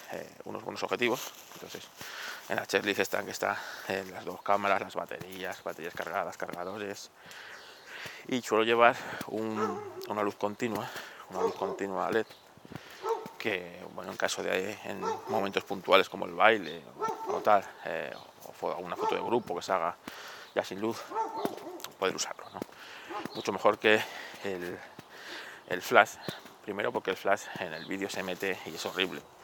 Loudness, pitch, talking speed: -32 LUFS, 115 Hz, 160 wpm